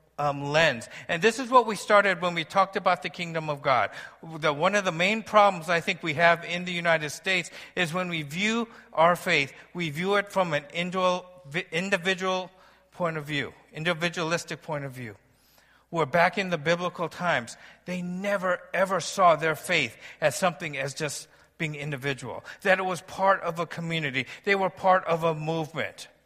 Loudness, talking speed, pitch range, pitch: -26 LUFS, 185 wpm, 160-185 Hz, 175 Hz